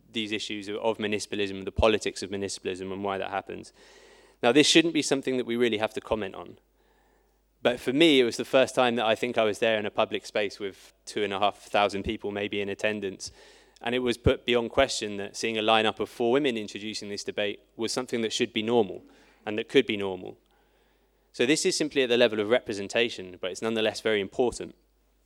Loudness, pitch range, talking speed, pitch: -27 LUFS, 105-120 Hz, 220 wpm, 110 Hz